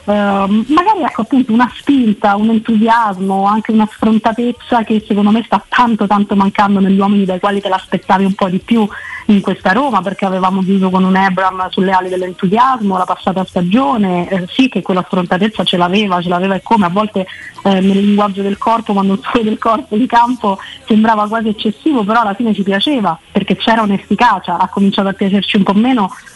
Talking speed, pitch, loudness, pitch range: 195 wpm, 205 Hz, -13 LUFS, 195-225 Hz